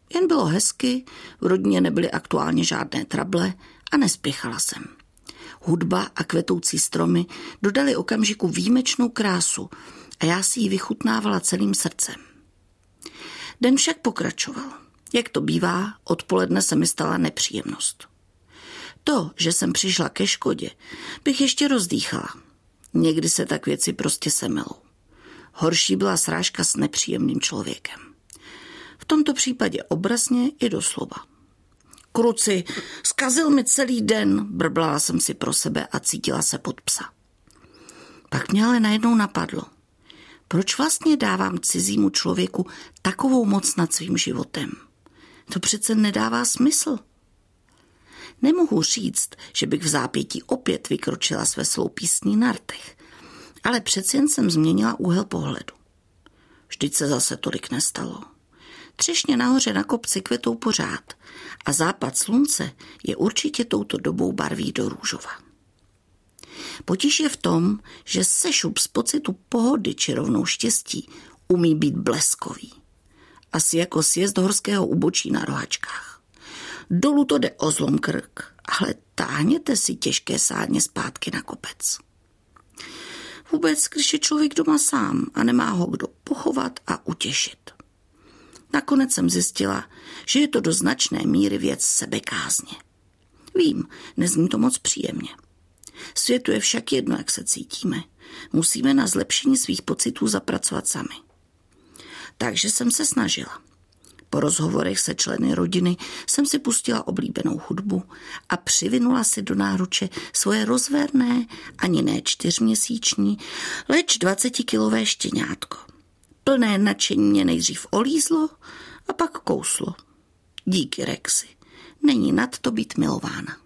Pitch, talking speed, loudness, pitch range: 240 Hz, 125 wpm, -22 LUFS, 180-285 Hz